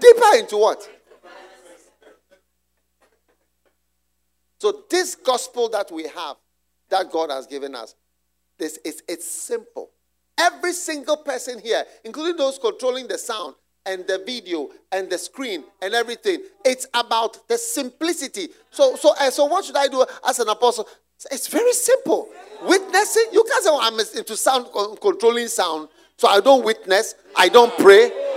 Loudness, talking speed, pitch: -19 LUFS, 140 wpm, 255 Hz